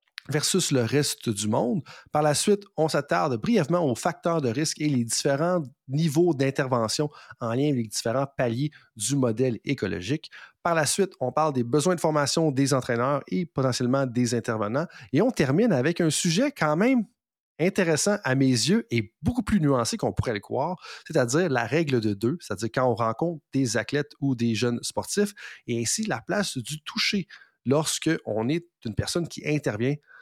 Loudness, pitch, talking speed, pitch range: -25 LUFS, 145 Hz, 185 wpm, 125-165 Hz